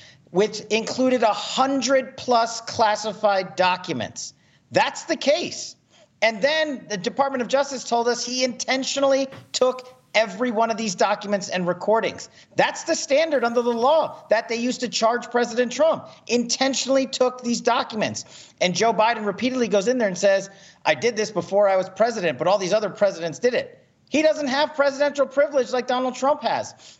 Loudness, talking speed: -22 LUFS, 170 wpm